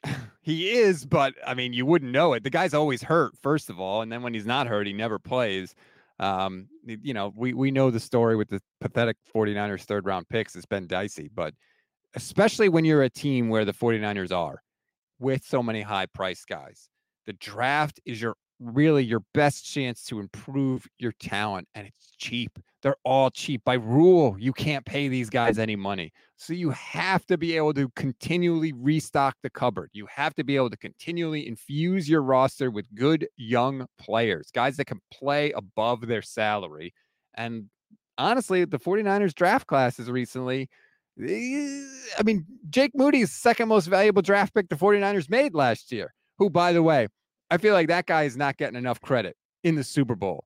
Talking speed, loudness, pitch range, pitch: 185 wpm, -25 LUFS, 115-165 Hz, 135 Hz